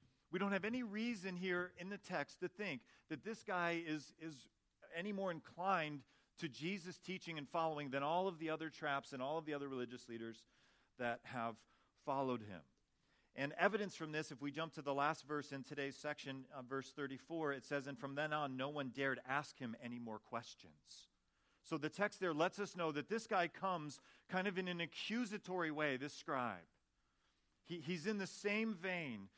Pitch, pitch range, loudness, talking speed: 155 Hz, 135-180 Hz, -44 LUFS, 200 wpm